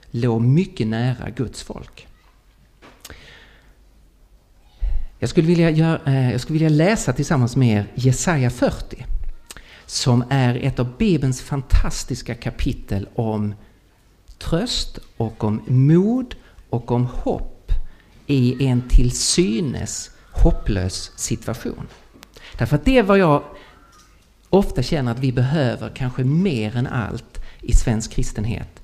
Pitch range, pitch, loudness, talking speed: 110-140 Hz, 125 Hz, -20 LUFS, 110 wpm